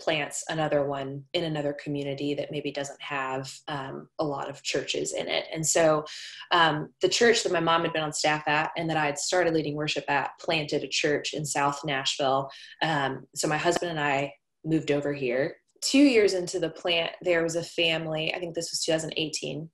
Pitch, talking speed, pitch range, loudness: 155 Hz, 205 wpm, 145-165 Hz, -27 LUFS